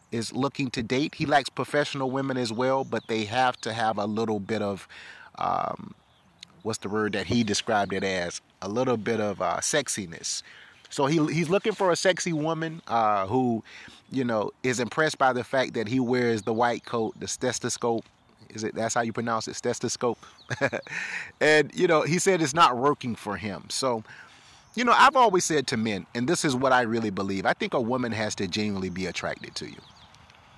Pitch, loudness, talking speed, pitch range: 120 Hz, -26 LUFS, 200 wpm, 110-135 Hz